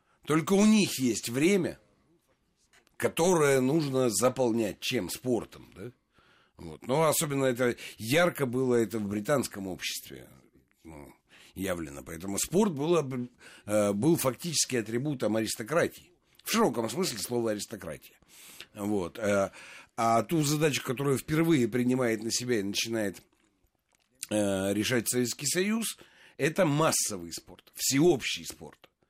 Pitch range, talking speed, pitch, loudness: 105-150 Hz, 110 wpm, 120 Hz, -28 LUFS